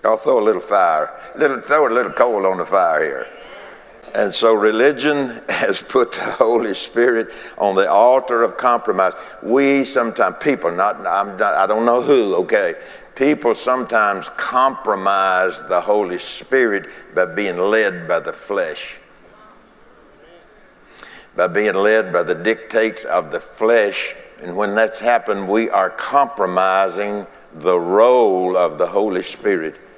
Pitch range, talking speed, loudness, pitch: 105-150 Hz, 145 wpm, -17 LUFS, 120 Hz